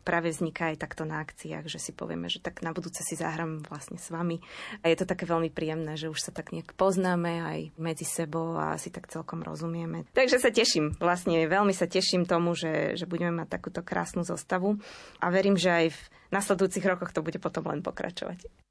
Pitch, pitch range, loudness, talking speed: 170 Hz, 165-185 Hz, -29 LUFS, 210 wpm